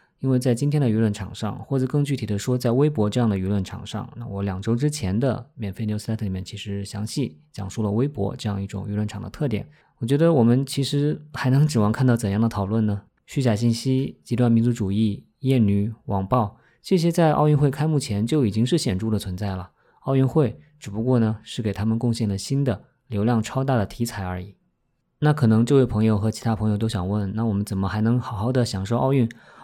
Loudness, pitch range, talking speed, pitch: -23 LUFS, 105-130 Hz, 350 characters per minute, 115 Hz